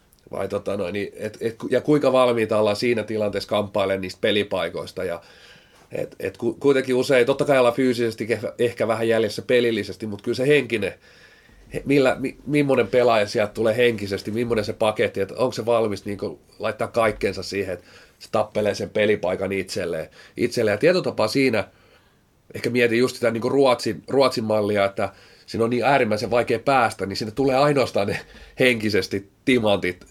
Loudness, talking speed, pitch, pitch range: -22 LUFS, 165 wpm, 115 Hz, 105-125 Hz